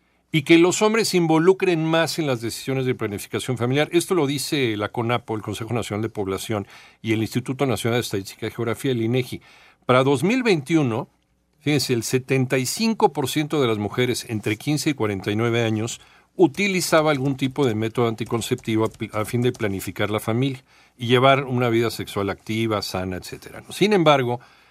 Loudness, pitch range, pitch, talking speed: -22 LUFS, 110-145 Hz, 120 Hz, 170 wpm